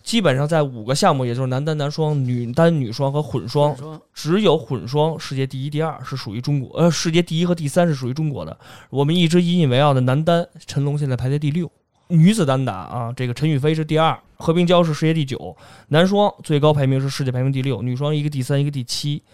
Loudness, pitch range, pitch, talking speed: -19 LUFS, 130-160 Hz, 145 Hz, 355 characters per minute